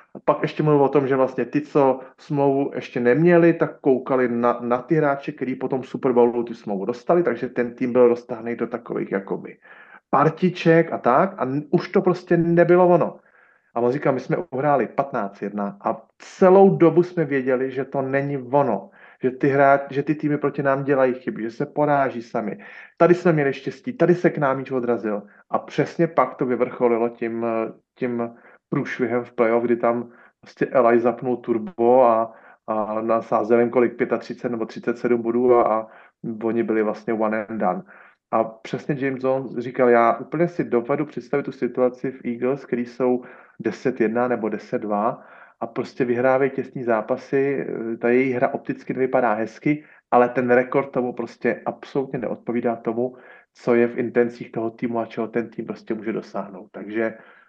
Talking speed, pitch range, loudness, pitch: 170 wpm, 120-140 Hz, -22 LUFS, 125 Hz